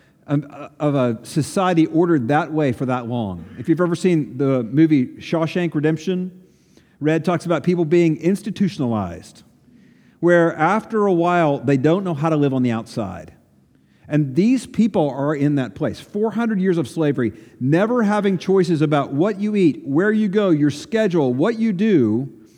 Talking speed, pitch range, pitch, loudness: 165 wpm, 140-185 Hz, 160 Hz, -19 LUFS